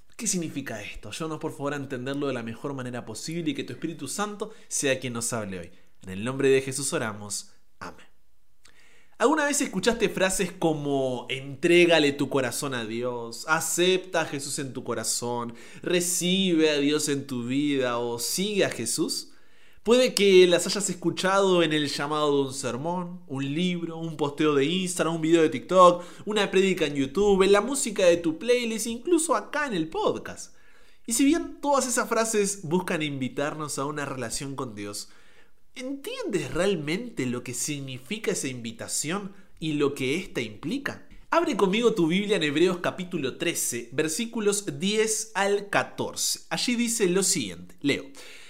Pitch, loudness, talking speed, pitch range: 160 Hz, -26 LUFS, 165 wpm, 135-195 Hz